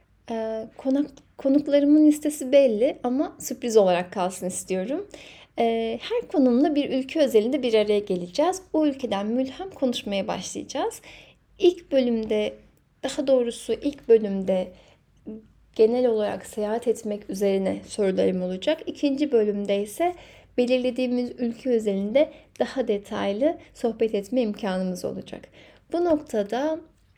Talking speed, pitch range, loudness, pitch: 110 wpm, 210-290 Hz, -24 LUFS, 245 Hz